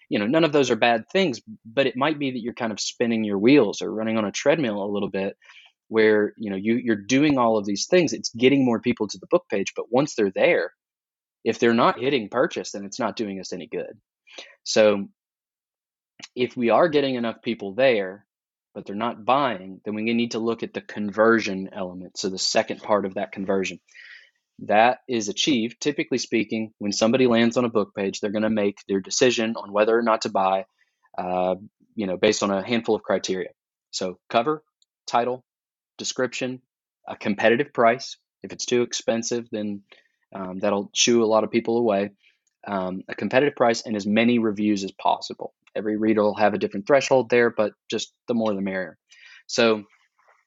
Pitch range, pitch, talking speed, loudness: 100-120 Hz, 110 Hz, 200 wpm, -23 LUFS